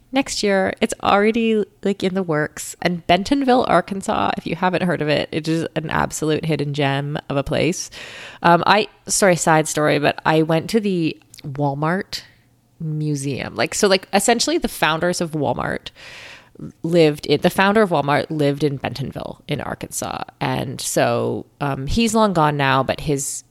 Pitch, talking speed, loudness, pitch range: 160 Hz, 170 wpm, -19 LUFS, 145-195 Hz